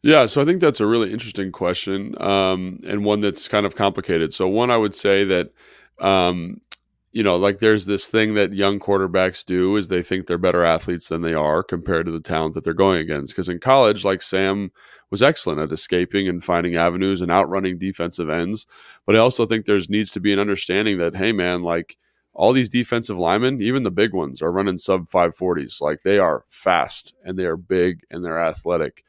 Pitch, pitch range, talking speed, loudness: 95 Hz, 90-105 Hz, 210 wpm, -20 LUFS